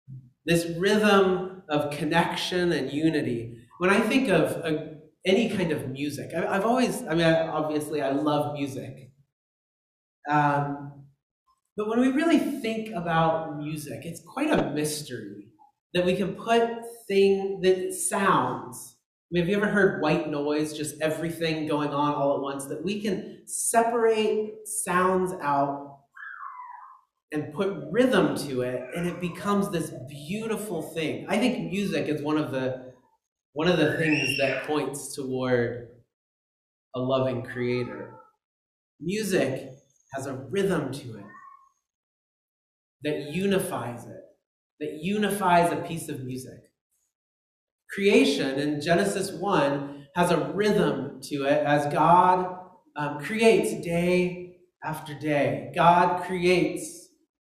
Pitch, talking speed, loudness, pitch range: 165 Hz, 130 wpm, -26 LUFS, 140-195 Hz